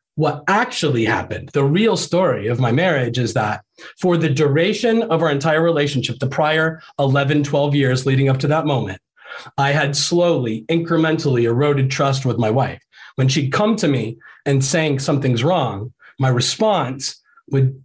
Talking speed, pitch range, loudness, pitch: 165 wpm, 130-160 Hz, -18 LUFS, 140 Hz